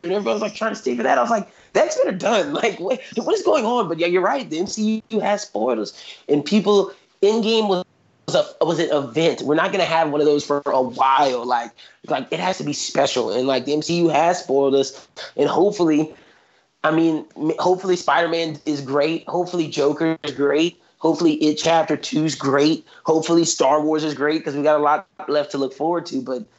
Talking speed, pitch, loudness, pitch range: 215 wpm, 160 Hz, -20 LUFS, 150-180 Hz